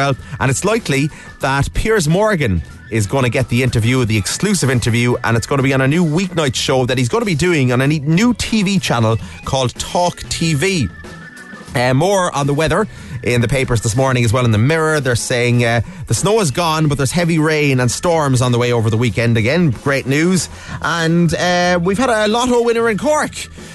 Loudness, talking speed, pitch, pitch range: -15 LUFS, 215 wpm, 140 Hz, 120-175 Hz